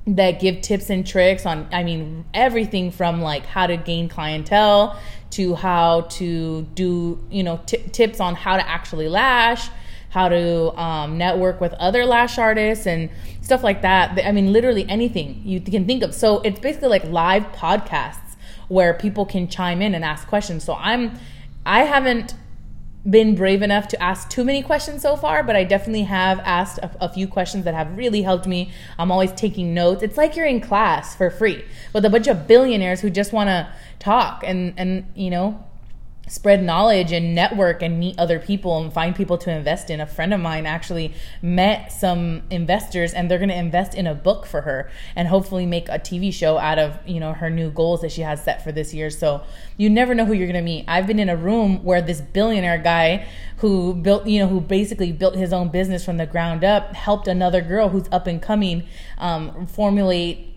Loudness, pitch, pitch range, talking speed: -20 LUFS, 185 Hz, 170-205 Hz, 205 wpm